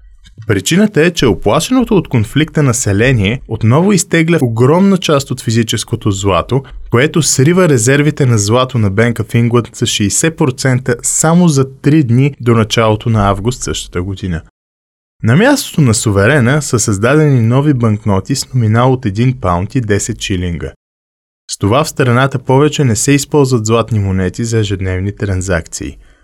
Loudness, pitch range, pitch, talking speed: -12 LUFS, 105-145 Hz, 120 Hz, 145 wpm